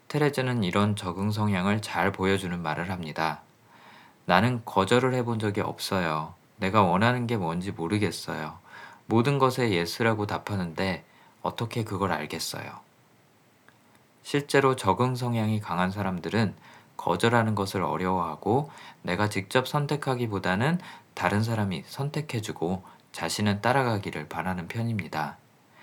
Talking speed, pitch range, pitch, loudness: 295 characters per minute, 90-120 Hz, 105 Hz, -27 LUFS